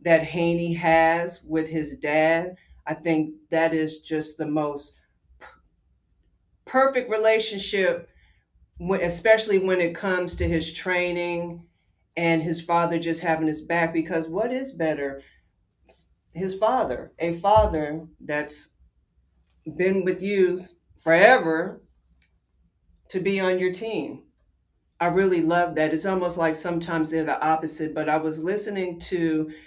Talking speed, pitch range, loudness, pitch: 130 wpm, 155-180 Hz, -24 LUFS, 165 Hz